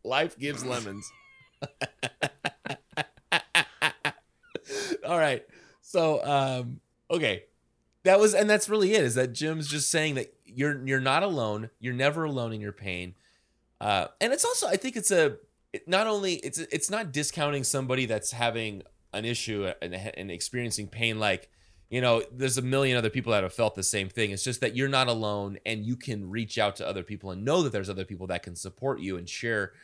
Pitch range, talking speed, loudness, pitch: 105-145 Hz, 185 wpm, -28 LUFS, 125 Hz